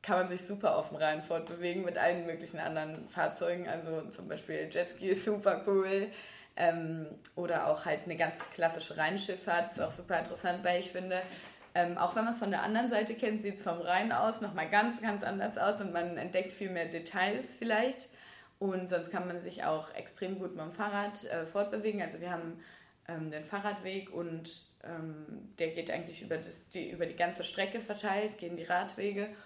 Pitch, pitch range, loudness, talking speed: 180 Hz, 170-205 Hz, -35 LUFS, 200 wpm